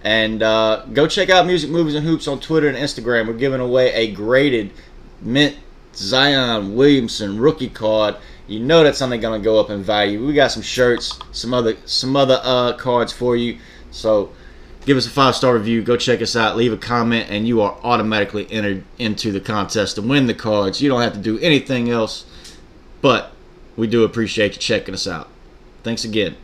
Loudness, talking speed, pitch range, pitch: -17 LUFS, 200 wpm, 110-130 Hz, 115 Hz